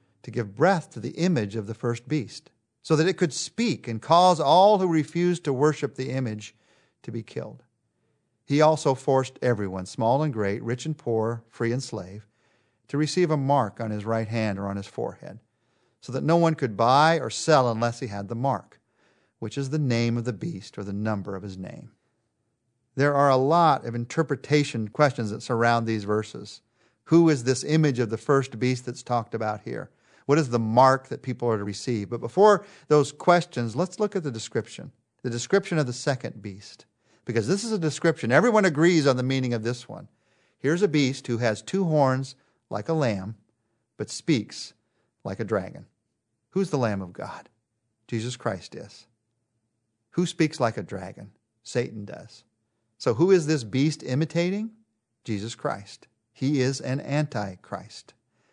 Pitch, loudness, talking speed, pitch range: 125 Hz, -25 LUFS, 185 wpm, 115-150 Hz